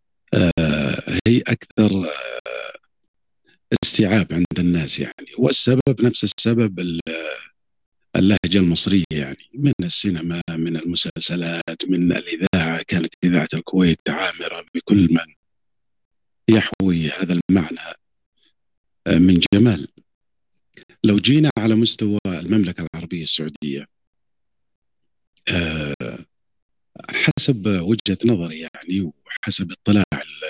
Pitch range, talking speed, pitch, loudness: 85-105 Hz, 85 wpm, 90 Hz, -19 LUFS